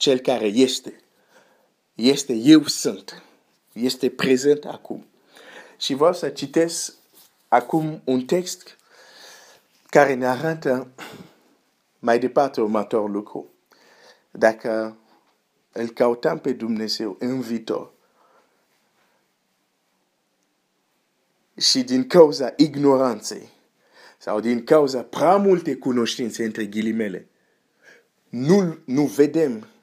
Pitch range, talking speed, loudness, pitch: 115-155 Hz, 90 wpm, -21 LUFS, 130 Hz